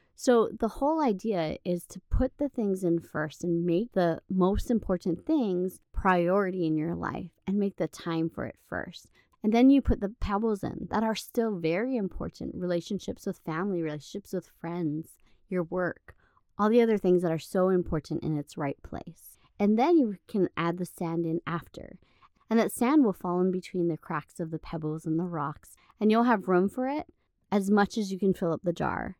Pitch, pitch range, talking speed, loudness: 185 Hz, 170-215 Hz, 205 wpm, -29 LUFS